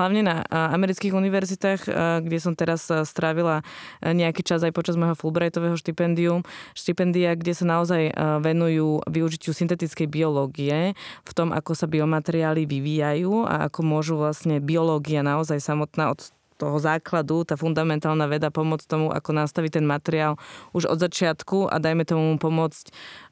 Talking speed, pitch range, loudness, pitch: 140 wpm, 155-170 Hz, -24 LUFS, 160 Hz